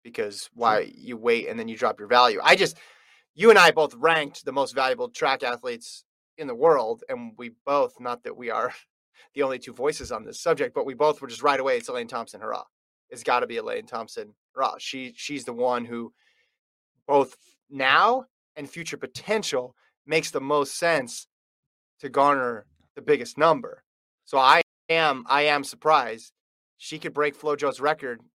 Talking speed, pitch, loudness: 180 wpm, 155 Hz, -24 LUFS